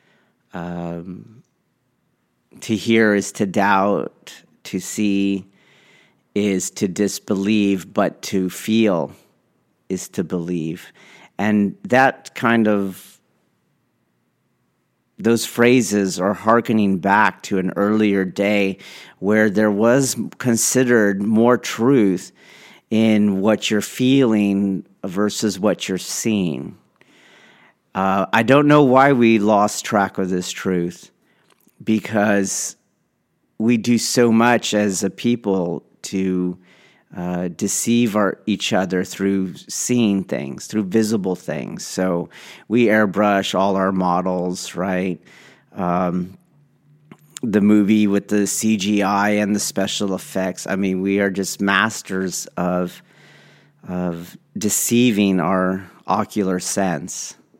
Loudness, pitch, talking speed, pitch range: -19 LUFS, 100 Hz, 110 wpm, 95-110 Hz